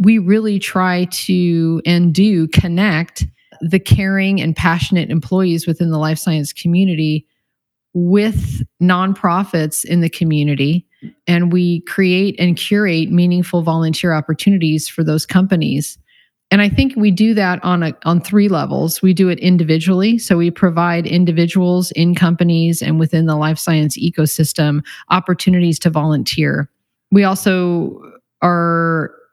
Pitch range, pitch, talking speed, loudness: 160-185 Hz, 175 Hz, 135 wpm, -15 LUFS